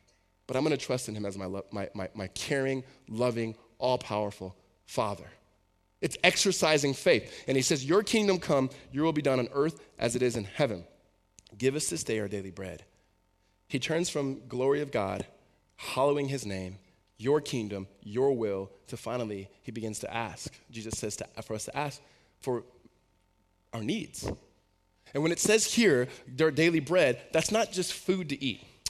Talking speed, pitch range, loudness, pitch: 180 wpm, 100-145 Hz, -30 LUFS, 120 Hz